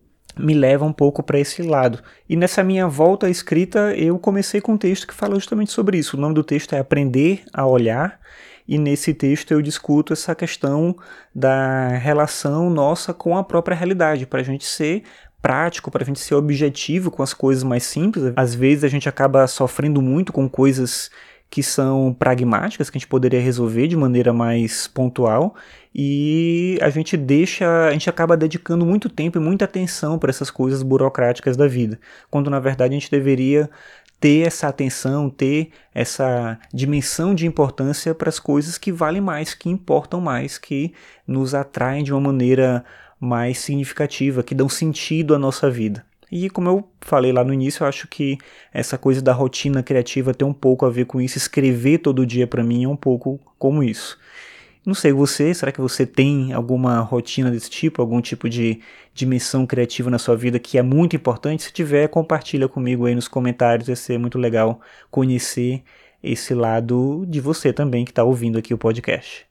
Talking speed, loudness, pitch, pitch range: 185 wpm, -19 LUFS, 140 Hz, 130-160 Hz